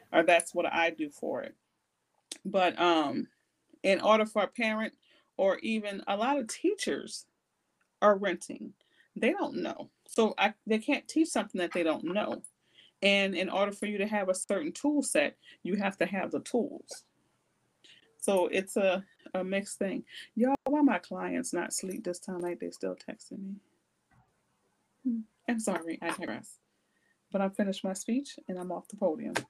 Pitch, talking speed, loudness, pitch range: 200 Hz, 175 wpm, -31 LUFS, 185-250 Hz